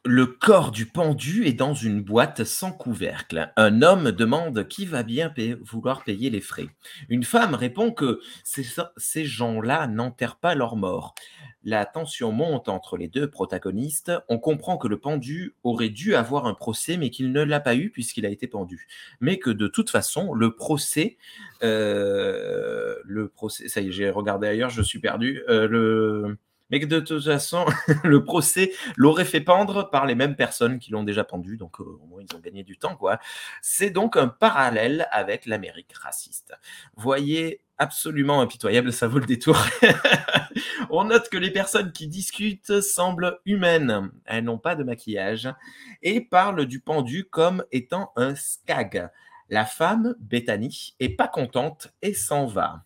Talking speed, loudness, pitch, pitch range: 175 wpm, -23 LUFS, 140 Hz, 115-175 Hz